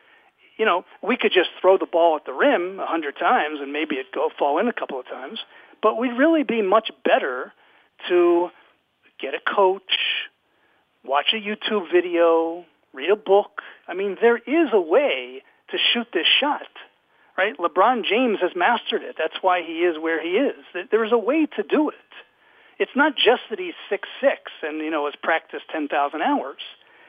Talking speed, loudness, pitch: 190 wpm, -21 LUFS, 215 Hz